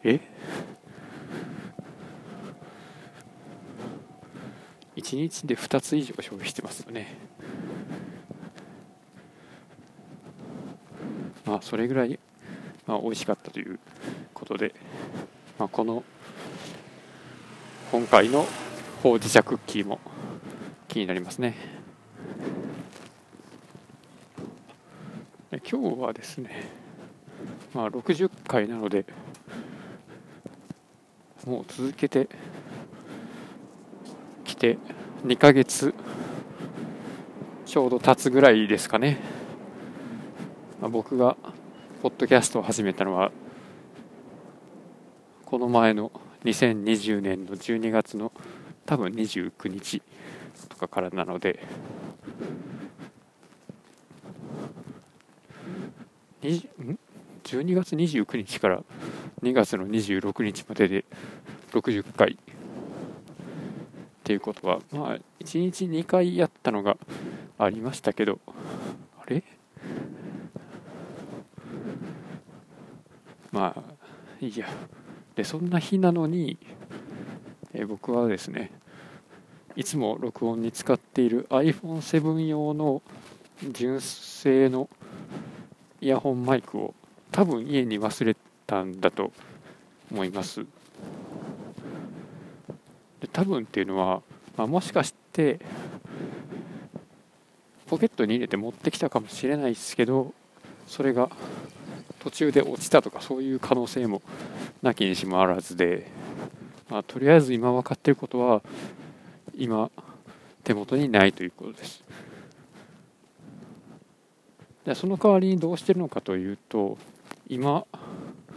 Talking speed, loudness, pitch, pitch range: 175 characters per minute, -26 LUFS, 130 Hz, 110-155 Hz